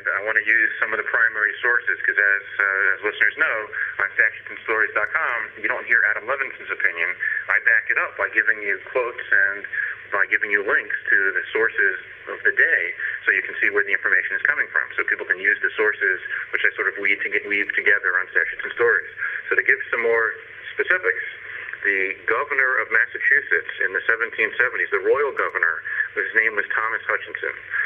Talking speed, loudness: 190 wpm, -20 LUFS